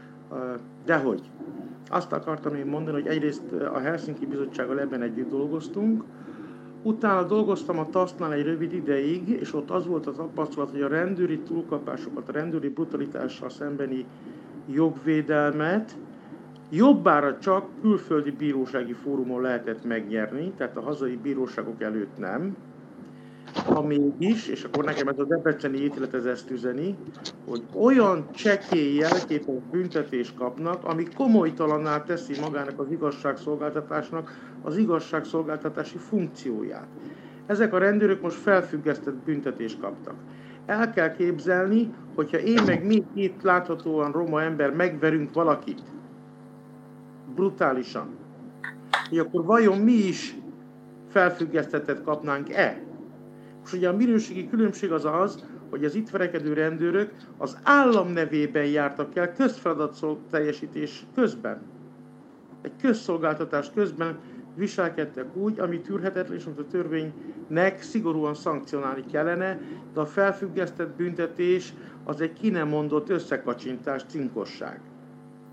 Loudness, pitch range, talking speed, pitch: -26 LUFS, 145-185 Hz, 115 wpm, 160 Hz